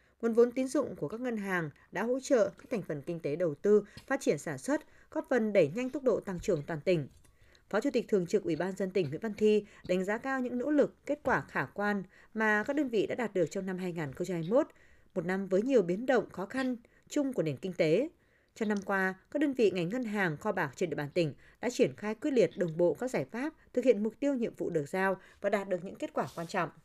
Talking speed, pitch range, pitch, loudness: 265 wpm, 180-250 Hz, 205 Hz, -32 LUFS